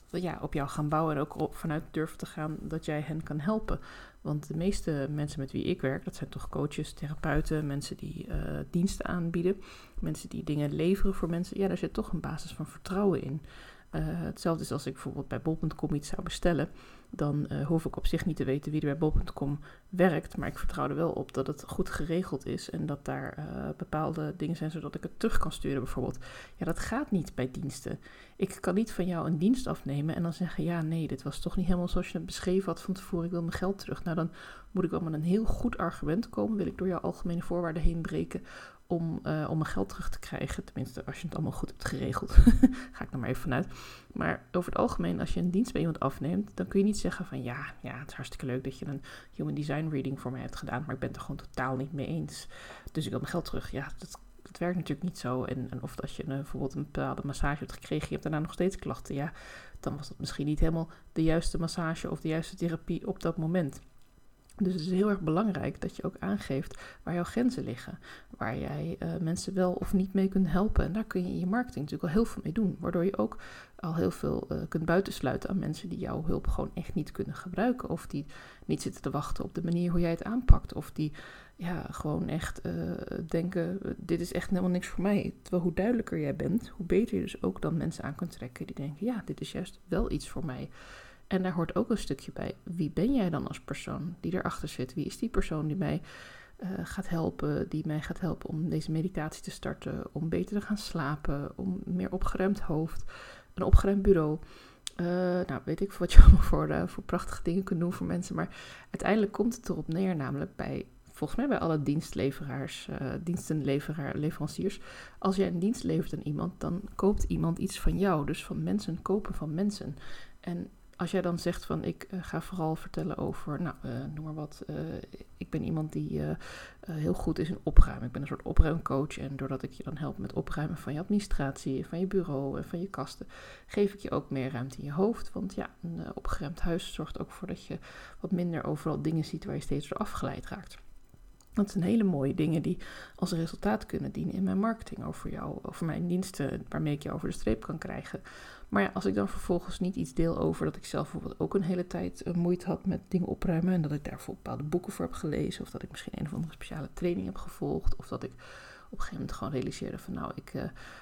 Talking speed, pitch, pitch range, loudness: 235 wpm, 170 Hz, 150-185 Hz, -33 LUFS